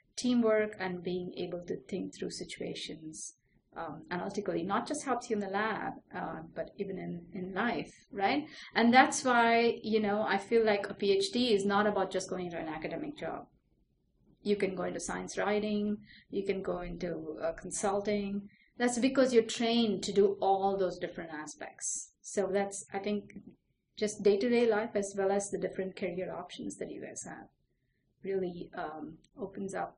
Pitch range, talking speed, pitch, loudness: 185-215 Hz, 180 wpm, 200 Hz, -33 LUFS